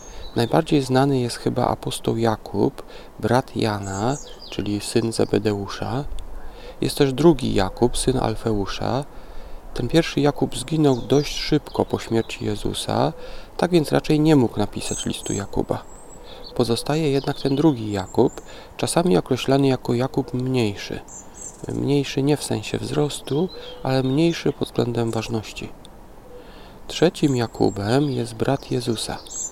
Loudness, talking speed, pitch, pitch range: -22 LUFS, 120 wpm, 125 Hz, 110-140 Hz